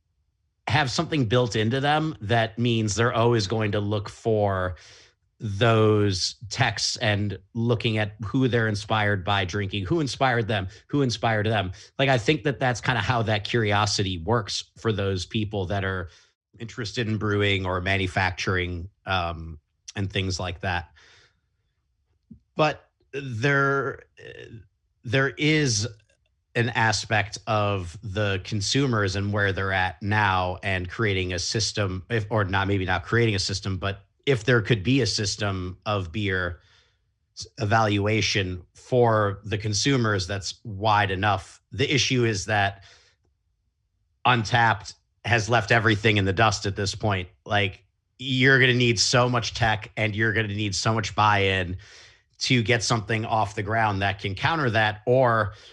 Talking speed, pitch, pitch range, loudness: 150 wpm, 105 Hz, 95-115 Hz, -24 LUFS